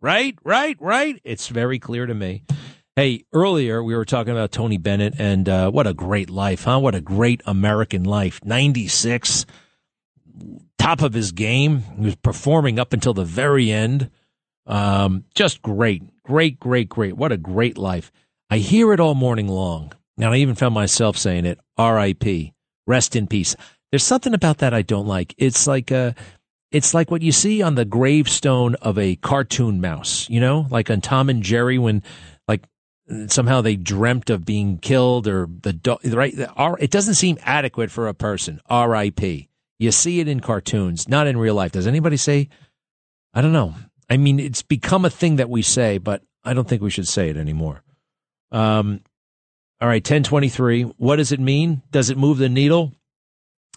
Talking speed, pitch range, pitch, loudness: 180 wpm, 105-140 Hz, 120 Hz, -19 LUFS